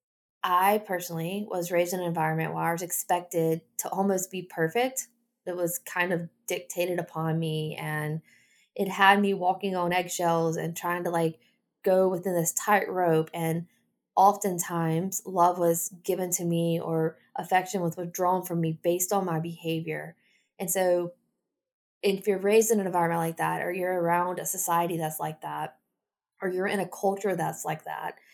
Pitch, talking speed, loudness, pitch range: 175 Hz, 170 wpm, -28 LUFS, 165-190 Hz